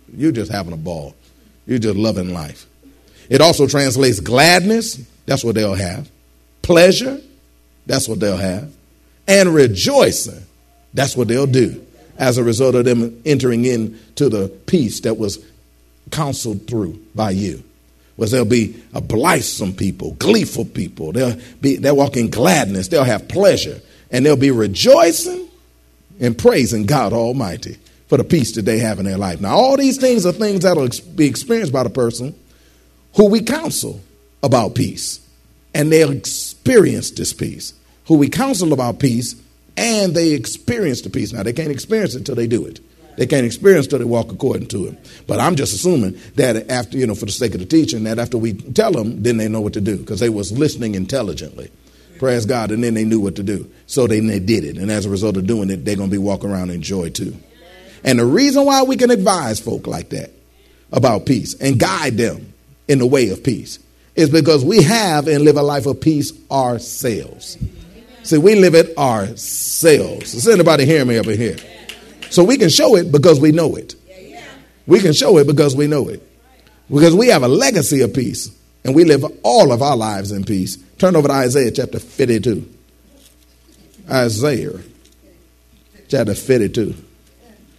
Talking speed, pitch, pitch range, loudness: 190 wpm, 120 Hz, 100-150 Hz, -15 LUFS